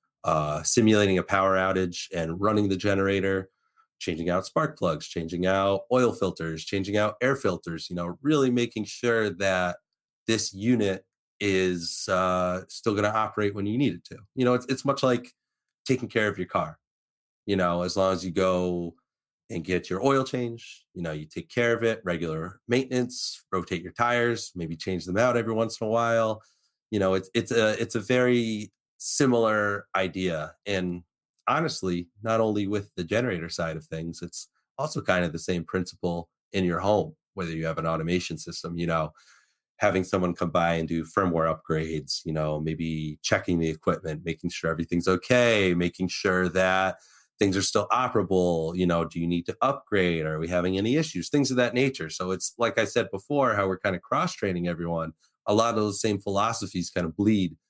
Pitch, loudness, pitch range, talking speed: 95 Hz, -26 LUFS, 85-110 Hz, 190 wpm